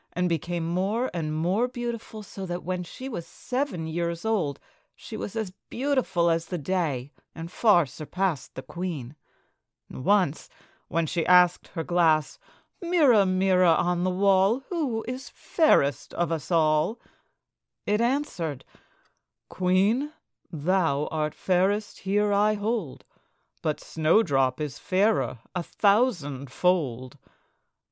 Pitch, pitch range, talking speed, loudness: 180 Hz, 165-215 Hz, 125 wpm, -26 LUFS